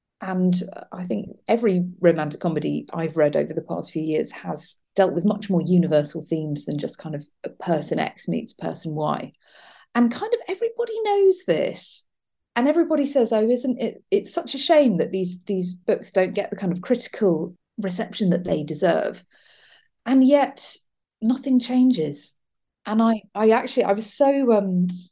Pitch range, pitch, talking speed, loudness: 175-255 Hz, 205 Hz, 170 wpm, -22 LUFS